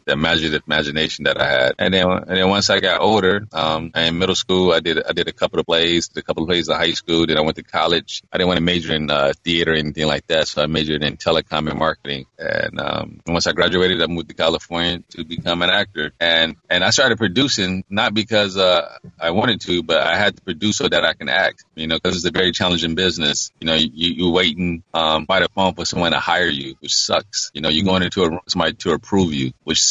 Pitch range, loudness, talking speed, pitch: 80-90 Hz, -18 LUFS, 260 wpm, 85 Hz